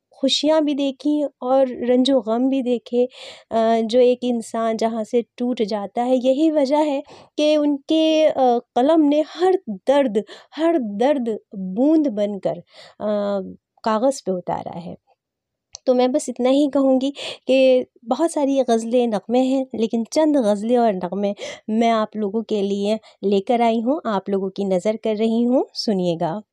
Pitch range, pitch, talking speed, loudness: 220-275 Hz, 245 Hz, 150 wpm, -20 LUFS